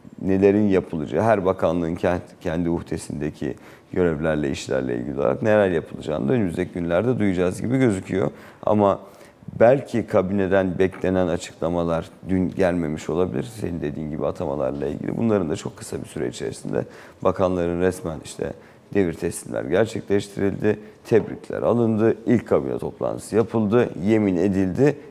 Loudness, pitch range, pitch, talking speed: -23 LUFS, 85-100 Hz, 95 Hz, 125 wpm